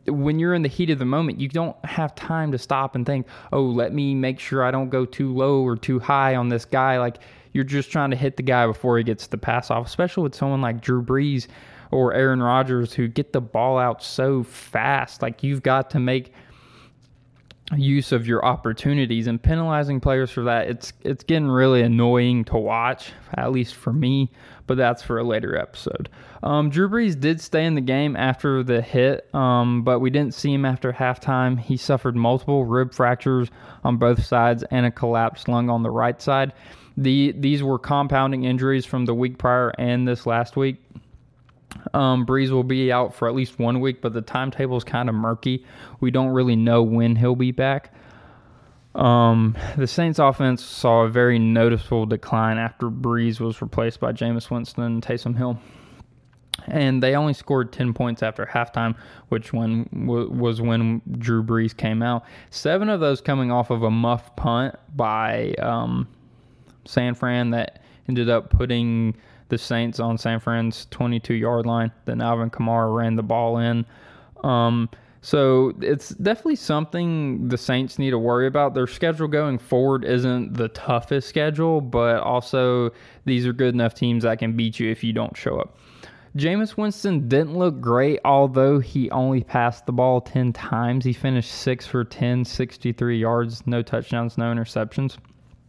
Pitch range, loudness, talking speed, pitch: 120-135 Hz, -22 LUFS, 185 wpm, 125 Hz